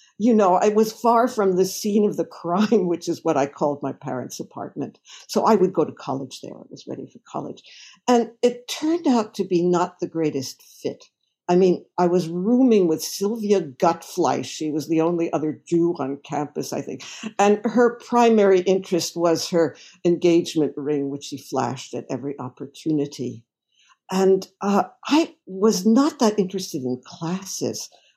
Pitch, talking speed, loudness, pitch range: 175 Hz, 175 wpm, -22 LUFS, 155-210 Hz